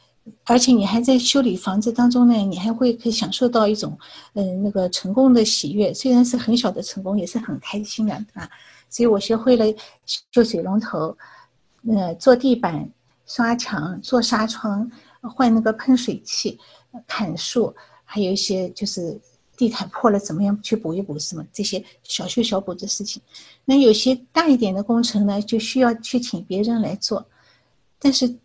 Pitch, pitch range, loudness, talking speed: 220 Hz, 200-245 Hz, -20 LUFS, 260 characters per minute